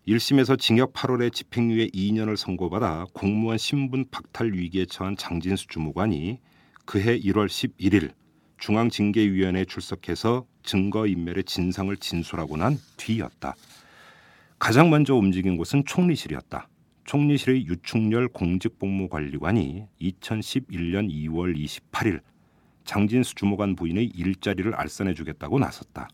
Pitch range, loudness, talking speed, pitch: 90-120 Hz, -25 LUFS, 285 characters per minute, 100 Hz